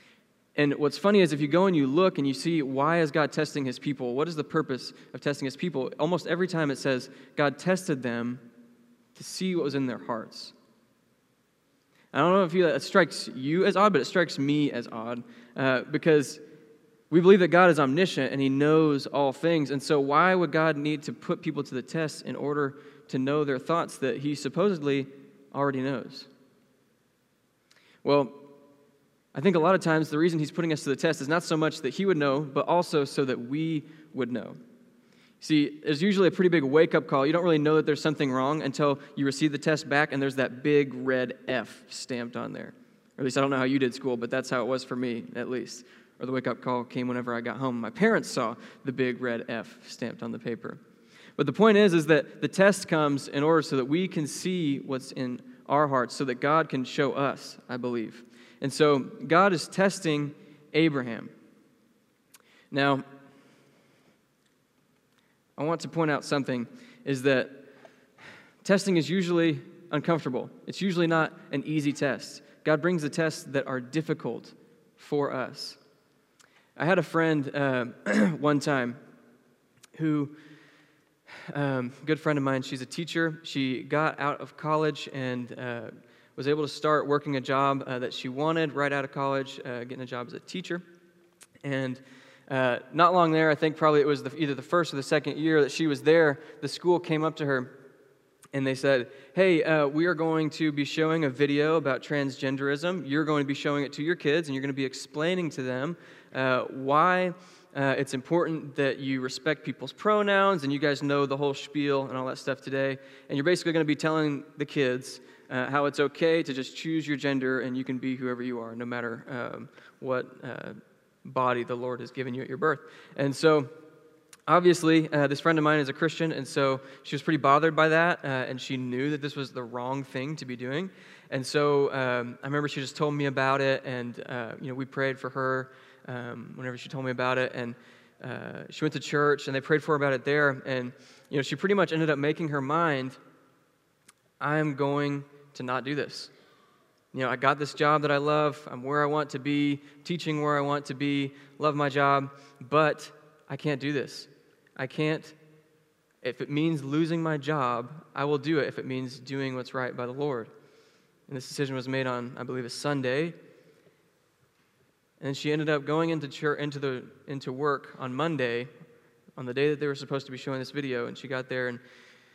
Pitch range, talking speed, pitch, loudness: 130-155 Hz, 210 wpm, 145 Hz, -27 LUFS